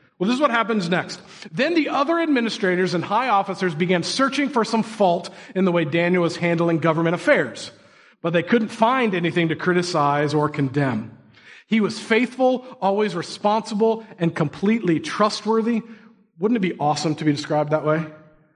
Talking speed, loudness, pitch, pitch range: 170 wpm, -21 LUFS, 185 Hz, 165-225 Hz